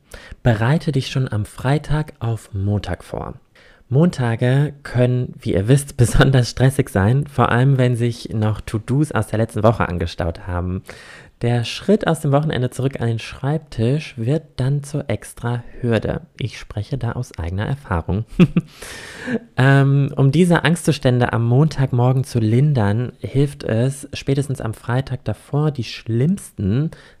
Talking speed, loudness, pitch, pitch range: 140 wpm, -19 LUFS, 125 Hz, 110-140 Hz